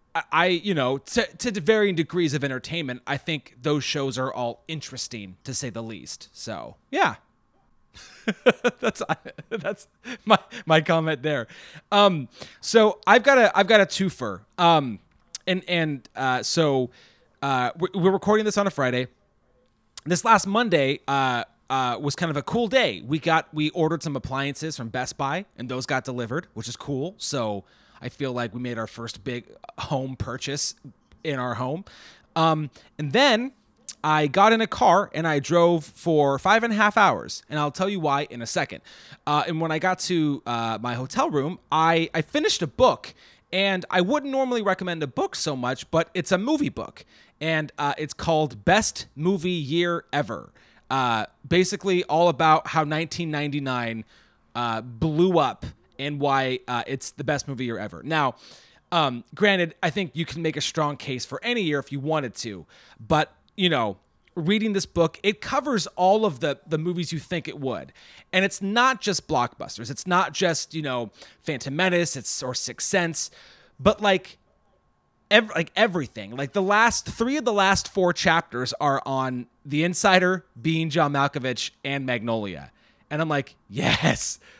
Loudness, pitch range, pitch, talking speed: -24 LUFS, 130-185 Hz, 155 Hz, 175 wpm